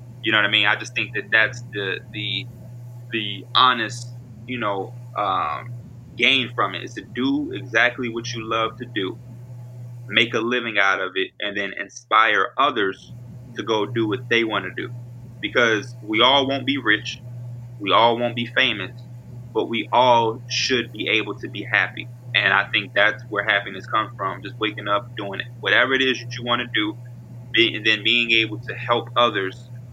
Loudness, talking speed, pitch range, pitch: -20 LUFS, 190 wpm, 110-120 Hz, 120 Hz